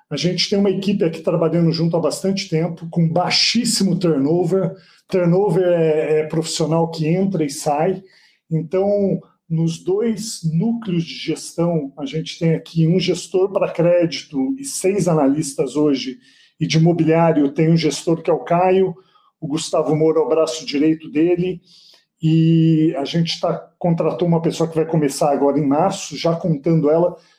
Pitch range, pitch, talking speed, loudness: 160-180 Hz, 165 Hz, 160 wpm, -18 LUFS